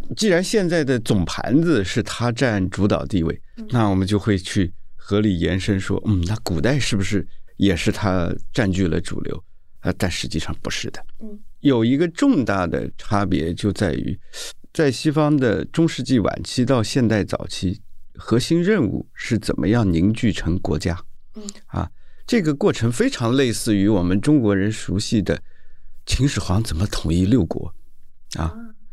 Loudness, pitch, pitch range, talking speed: -21 LUFS, 105 Hz, 95-130 Hz, 240 characters per minute